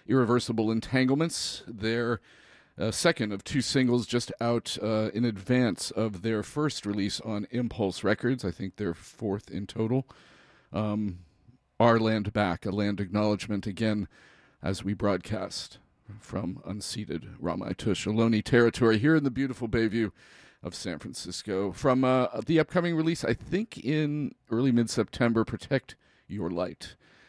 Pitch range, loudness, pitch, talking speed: 100-125 Hz, -29 LUFS, 110 Hz, 140 wpm